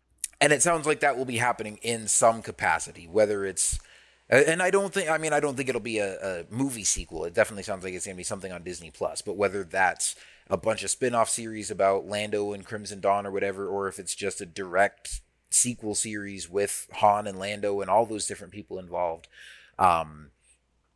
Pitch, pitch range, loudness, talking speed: 105 Hz, 95-115 Hz, -26 LUFS, 215 wpm